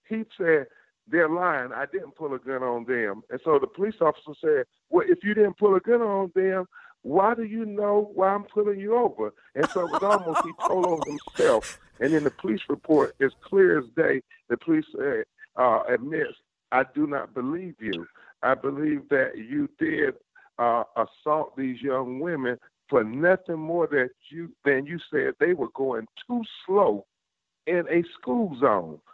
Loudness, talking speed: -25 LUFS, 185 wpm